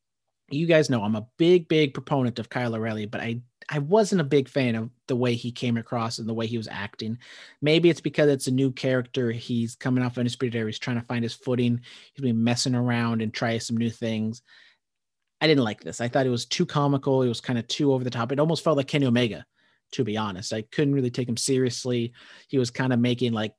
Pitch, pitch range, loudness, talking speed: 125 Hz, 115-140 Hz, -25 LUFS, 245 wpm